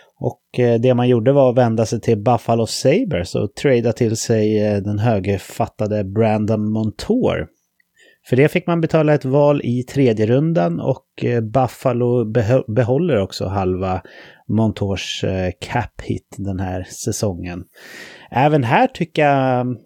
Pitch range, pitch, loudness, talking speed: 105-130 Hz, 120 Hz, -18 LUFS, 135 wpm